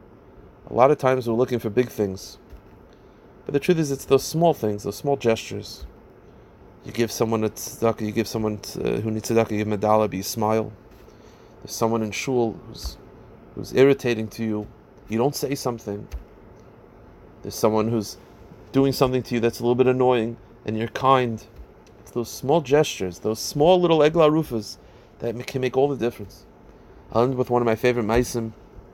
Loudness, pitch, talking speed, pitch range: -23 LUFS, 115 Hz, 185 wpm, 105-130 Hz